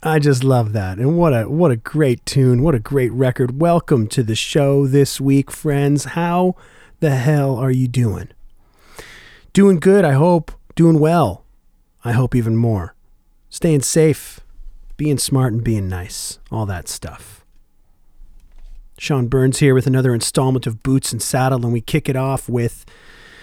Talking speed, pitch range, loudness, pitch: 165 wpm, 120-155 Hz, -17 LUFS, 130 Hz